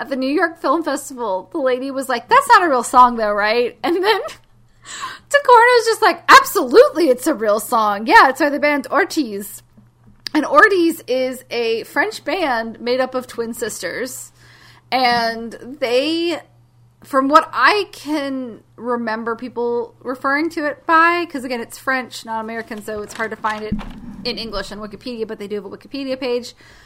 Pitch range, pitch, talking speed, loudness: 225-300 Hz, 255 Hz, 180 wpm, -17 LUFS